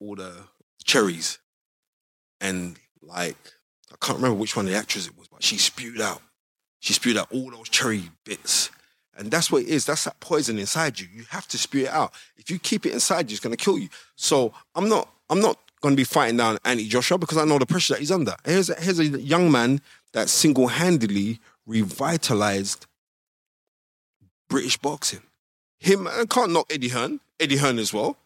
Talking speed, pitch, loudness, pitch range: 200 wpm, 130 Hz, -23 LUFS, 110-160 Hz